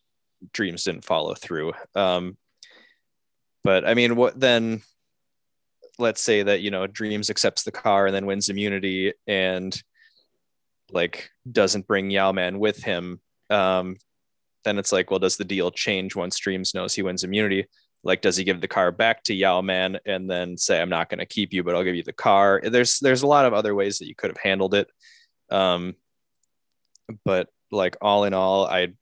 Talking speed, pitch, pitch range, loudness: 190 wpm, 100 Hz, 95-105 Hz, -23 LUFS